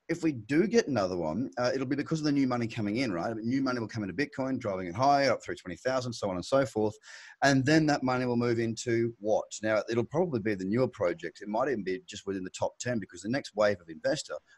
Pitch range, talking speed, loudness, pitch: 110-135 Hz, 275 wpm, -30 LUFS, 120 Hz